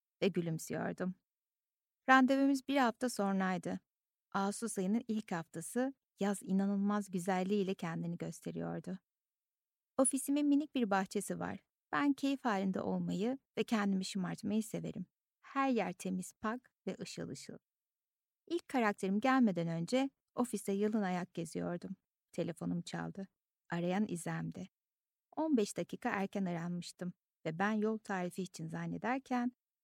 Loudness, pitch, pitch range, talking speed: -37 LUFS, 200 Hz, 175-245 Hz, 115 wpm